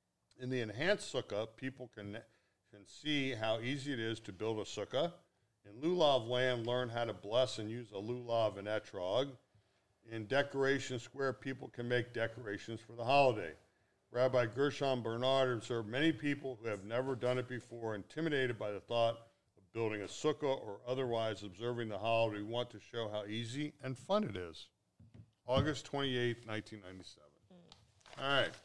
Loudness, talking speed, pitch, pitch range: -37 LUFS, 165 wpm, 120 Hz, 110-130 Hz